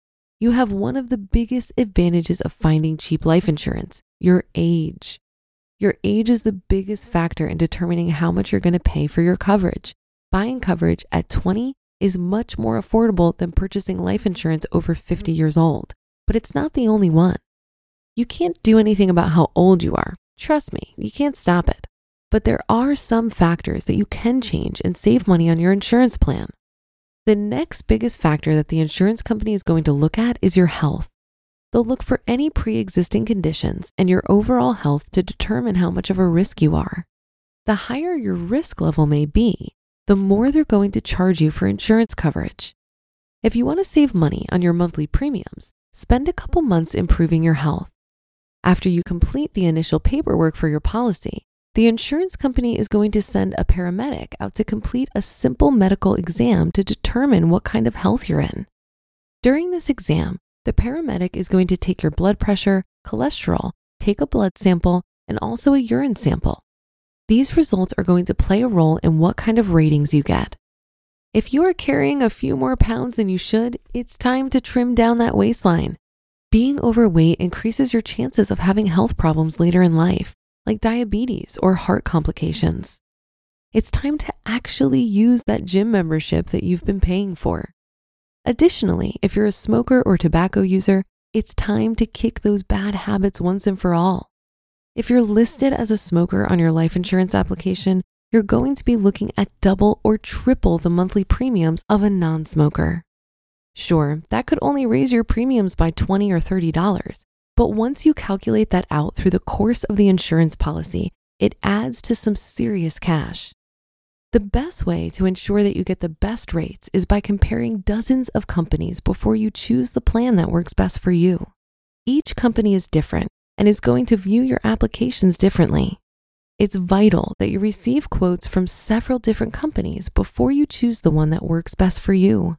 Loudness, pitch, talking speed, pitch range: -19 LUFS, 195 Hz, 185 wpm, 170-230 Hz